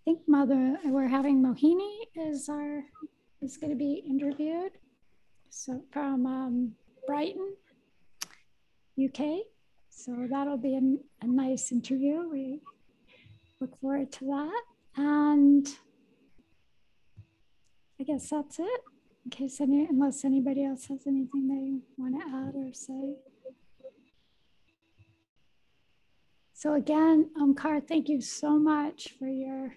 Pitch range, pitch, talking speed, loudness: 265-295 Hz, 275 Hz, 115 wpm, -29 LUFS